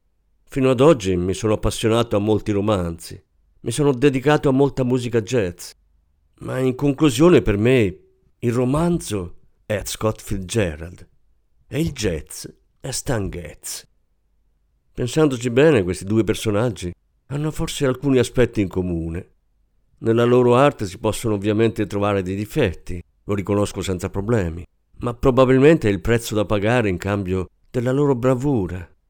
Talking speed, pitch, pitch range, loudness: 140 wpm, 110 Hz, 95-130 Hz, -20 LUFS